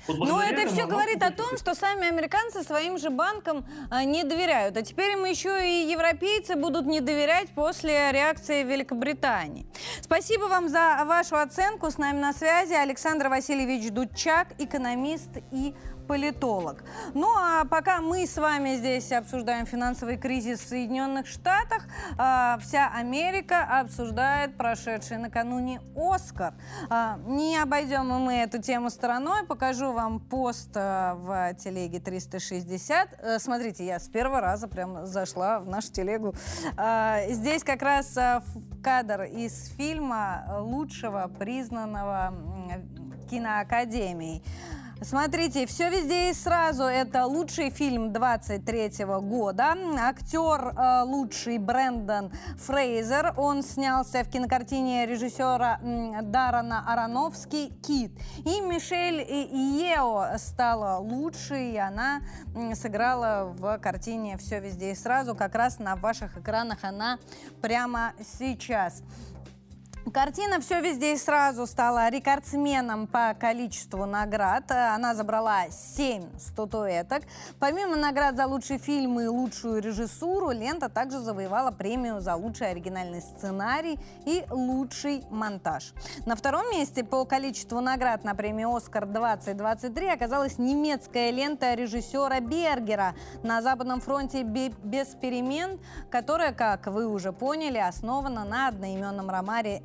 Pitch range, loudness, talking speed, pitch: 220-290 Hz, -28 LUFS, 120 wpm, 255 Hz